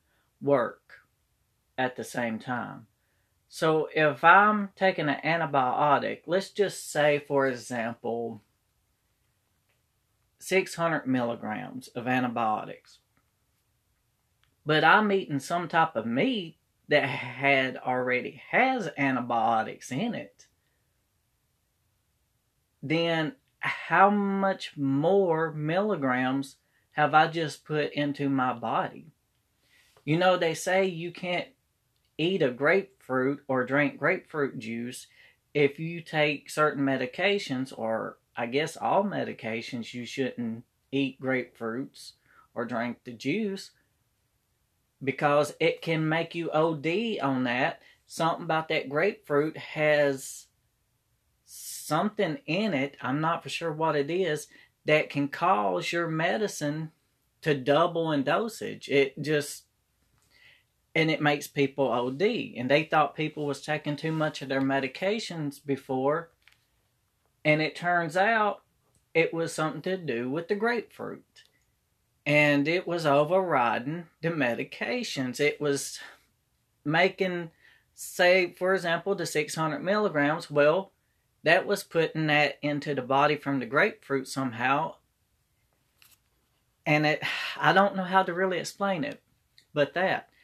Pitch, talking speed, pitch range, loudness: 150 Hz, 120 wpm, 130-170 Hz, -27 LUFS